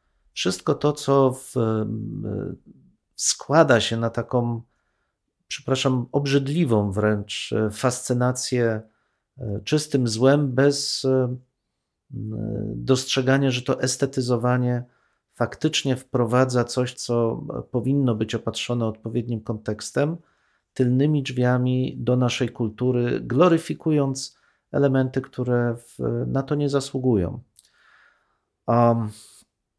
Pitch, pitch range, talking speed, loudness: 125 Hz, 115-135 Hz, 85 wpm, -23 LUFS